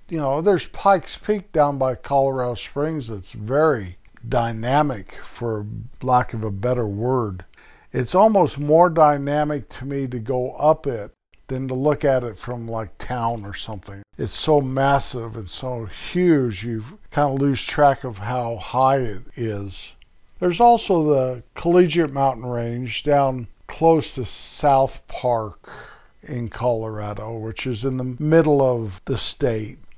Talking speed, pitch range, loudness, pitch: 150 wpm, 115-145 Hz, -21 LUFS, 125 Hz